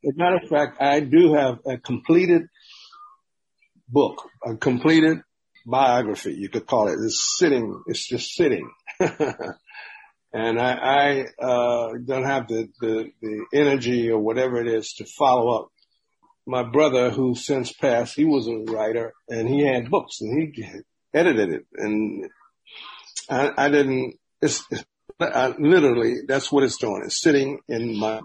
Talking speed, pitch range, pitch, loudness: 150 wpm, 115-150 Hz, 130 Hz, -22 LUFS